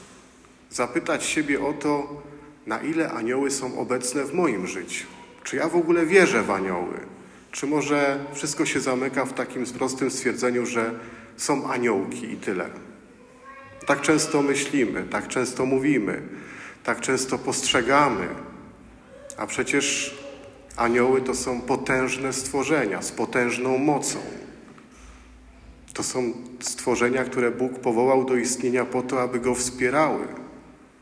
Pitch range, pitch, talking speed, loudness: 125-140 Hz, 130 Hz, 125 wpm, -24 LUFS